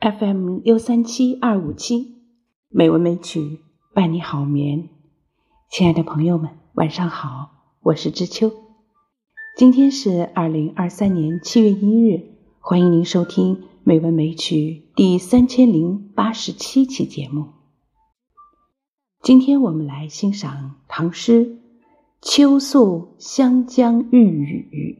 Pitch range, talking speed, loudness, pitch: 160-245 Hz, 180 characters per minute, -17 LUFS, 190 Hz